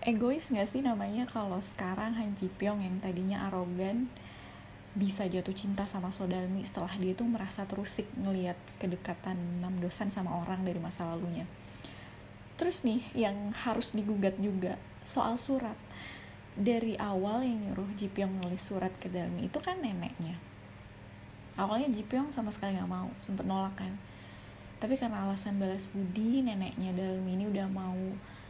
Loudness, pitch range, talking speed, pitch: -35 LUFS, 180-215 Hz, 150 wpm, 195 Hz